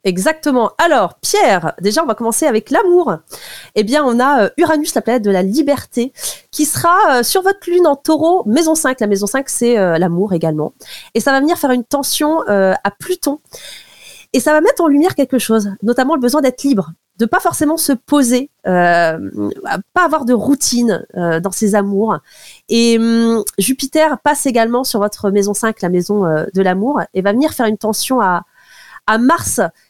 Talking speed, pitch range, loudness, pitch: 185 wpm, 205-295 Hz, -14 LUFS, 245 Hz